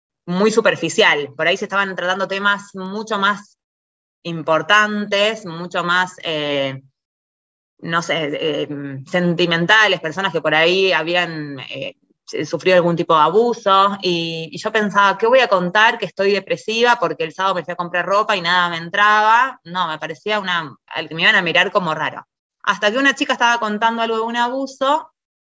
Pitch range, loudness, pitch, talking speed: 165-210 Hz, -17 LUFS, 185 Hz, 175 wpm